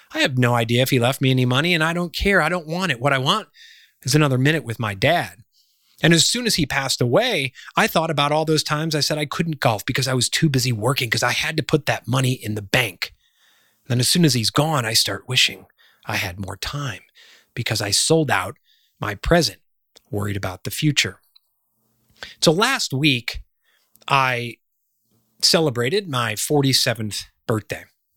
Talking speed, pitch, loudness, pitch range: 200 wpm, 130 Hz, -20 LUFS, 115-155 Hz